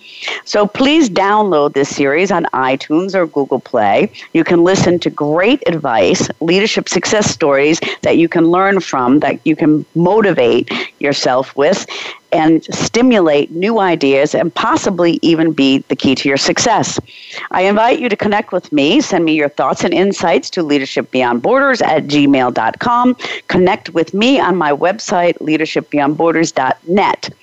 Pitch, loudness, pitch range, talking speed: 165 Hz, -13 LUFS, 145-195 Hz, 145 wpm